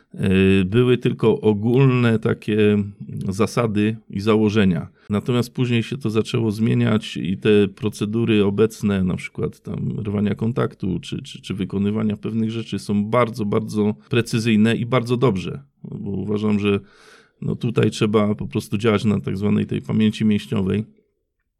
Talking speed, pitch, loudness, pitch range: 140 wpm, 110 Hz, -20 LUFS, 105-115 Hz